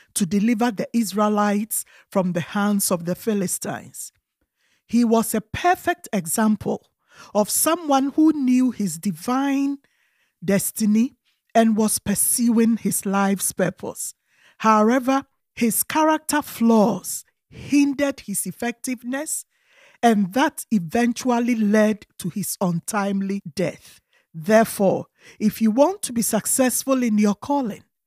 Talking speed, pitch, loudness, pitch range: 115 wpm, 225 Hz, -21 LUFS, 200-260 Hz